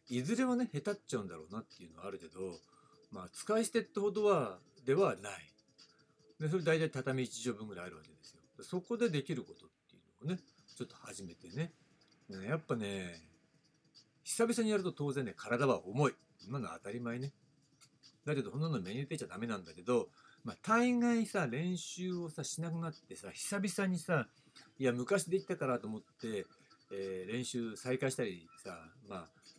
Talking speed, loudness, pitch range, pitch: 350 characters per minute, -37 LUFS, 125-190 Hz, 155 Hz